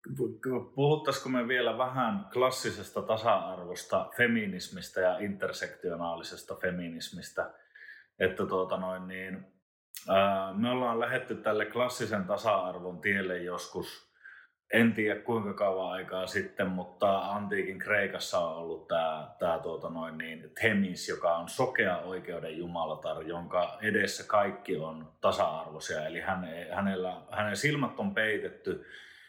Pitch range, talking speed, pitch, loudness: 90-125 Hz, 115 wpm, 100 Hz, -32 LUFS